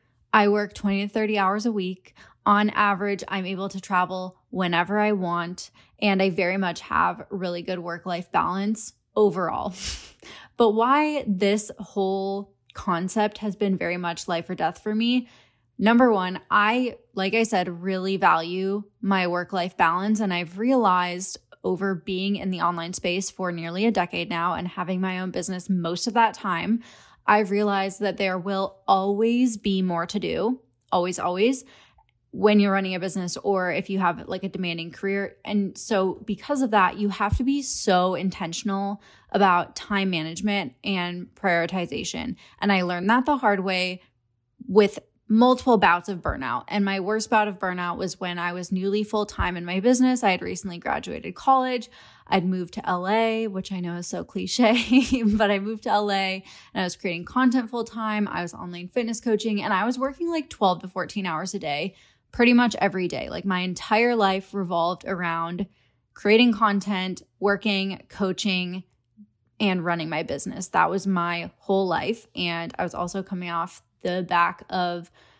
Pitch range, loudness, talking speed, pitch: 180-210 Hz, -24 LUFS, 175 wpm, 195 Hz